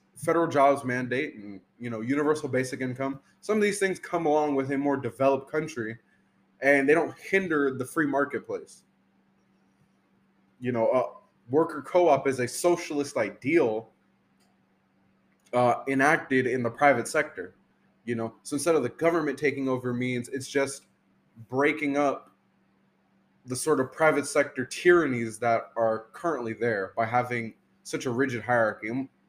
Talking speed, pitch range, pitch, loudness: 150 wpm, 120-150 Hz, 135 Hz, -27 LUFS